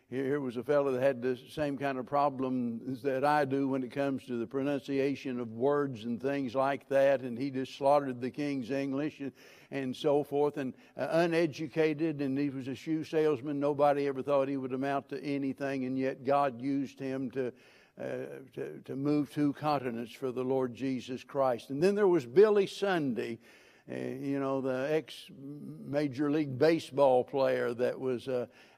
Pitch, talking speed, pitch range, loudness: 135 Hz, 185 wpm, 130-145 Hz, -32 LUFS